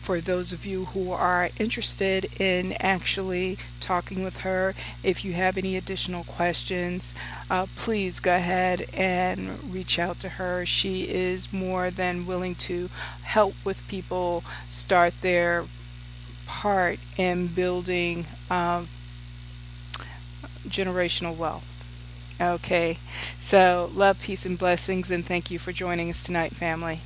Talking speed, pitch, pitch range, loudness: 130 wpm, 180 Hz, 165-185 Hz, -26 LUFS